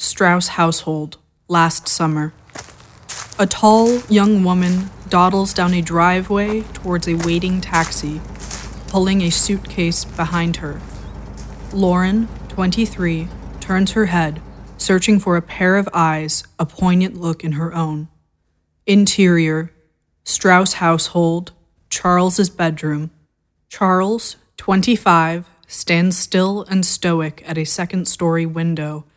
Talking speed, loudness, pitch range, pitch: 110 wpm, -16 LUFS, 165-190 Hz, 175 Hz